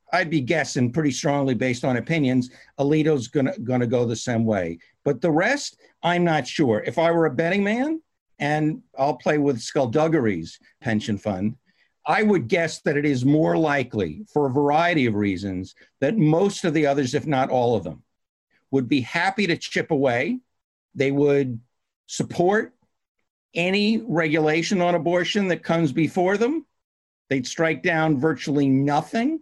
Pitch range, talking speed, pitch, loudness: 130-170 Hz, 160 wpm, 150 Hz, -22 LUFS